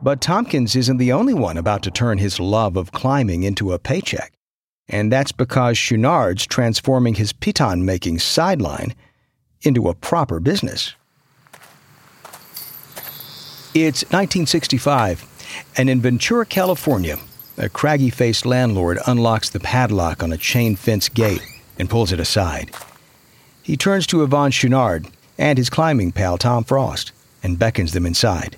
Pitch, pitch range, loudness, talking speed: 120 Hz, 100-135 Hz, -18 LUFS, 135 wpm